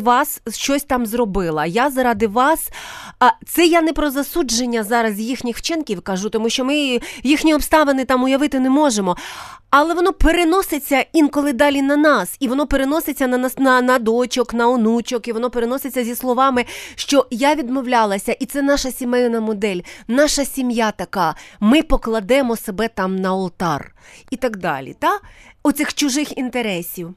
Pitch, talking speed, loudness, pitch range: 255 Hz, 155 wpm, -18 LUFS, 230-285 Hz